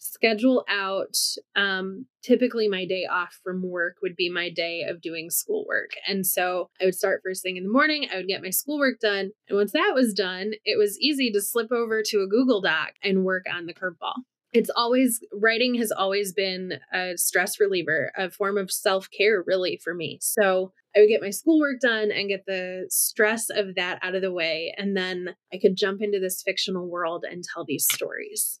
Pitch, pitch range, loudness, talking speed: 195 Hz, 185-230 Hz, -24 LUFS, 210 wpm